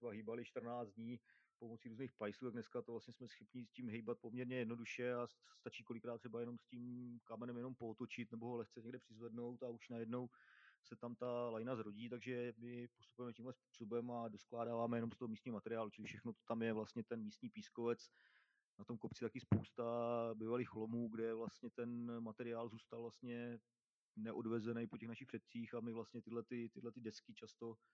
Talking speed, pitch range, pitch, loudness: 185 wpm, 115-120 Hz, 120 Hz, -48 LUFS